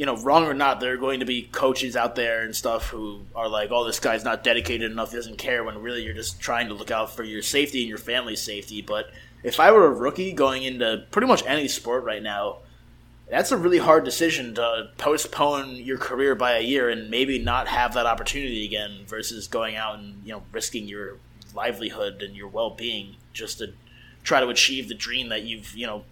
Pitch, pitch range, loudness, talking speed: 115 Hz, 110-130 Hz, -24 LUFS, 225 wpm